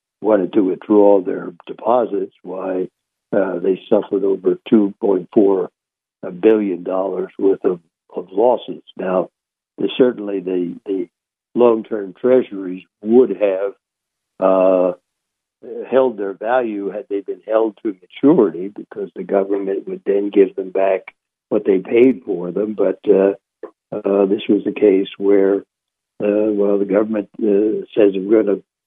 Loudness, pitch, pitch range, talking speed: -17 LUFS, 100 Hz, 95-110 Hz, 135 wpm